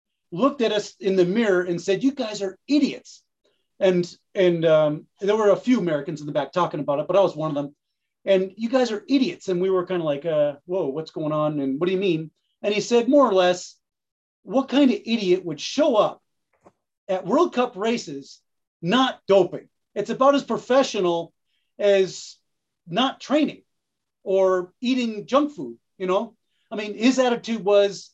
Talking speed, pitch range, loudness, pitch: 190 wpm, 180-245 Hz, -22 LUFS, 195 Hz